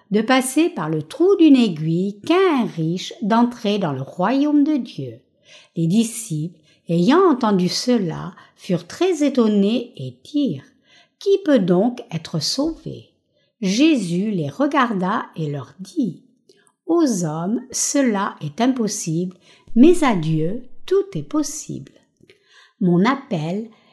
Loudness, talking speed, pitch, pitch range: -19 LUFS, 125 wpm, 215 Hz, 175-275 Hz